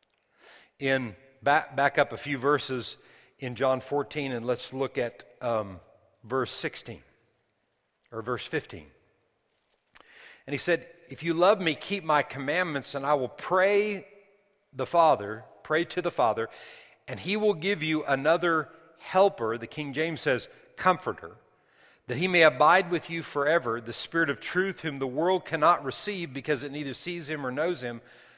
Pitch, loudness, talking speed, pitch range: 150 Hz, -27 LUFS, 160 wpm, 130-170 Hz